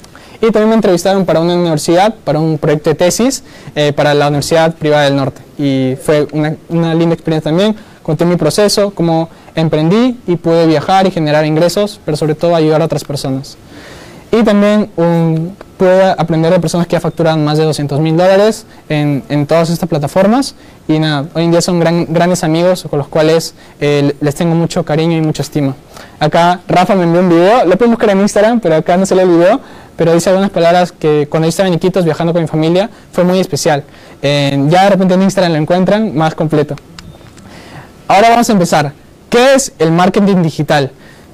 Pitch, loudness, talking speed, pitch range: 165 Hz, -11 LUFS, 200 wpm, 155-185 Hz